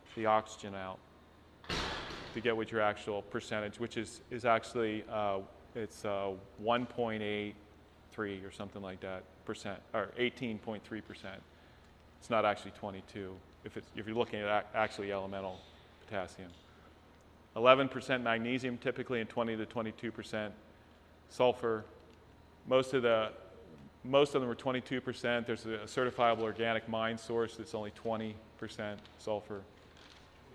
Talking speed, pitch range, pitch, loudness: 135 wpm, 95-115 Hz, 110 Hz, -36 LUFS